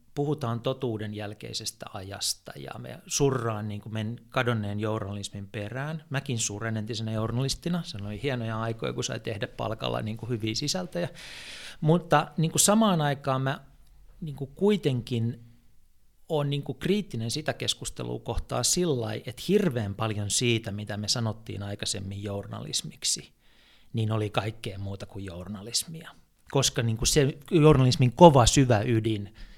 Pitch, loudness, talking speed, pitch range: 120 Hz, -27 LUFS, 140 wpm, 105-140 Hz